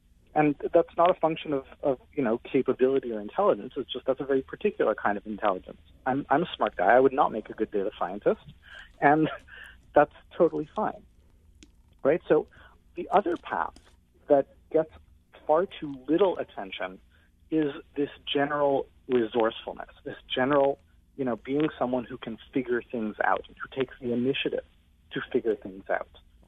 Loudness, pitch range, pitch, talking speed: -28 LUFS, 110-150 Hz, 135 Hz, 165 wpm